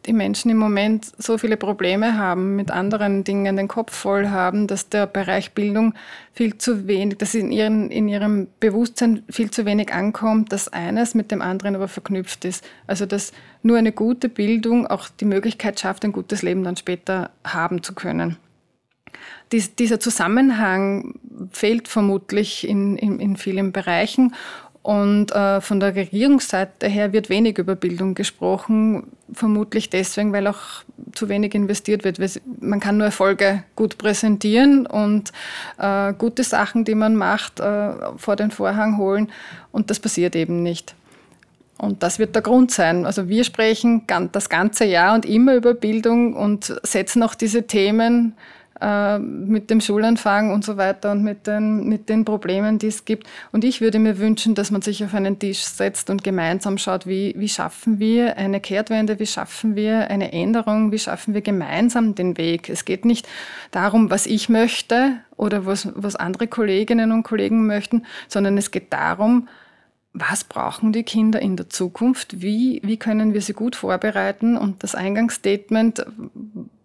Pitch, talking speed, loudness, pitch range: 210 Hz, 170 wpm, -20 LUFS, 195-225 Hz